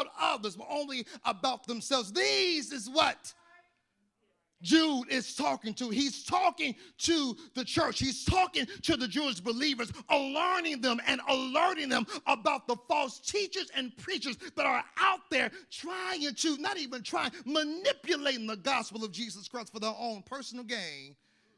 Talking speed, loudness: 150 wpm, -31 LUFS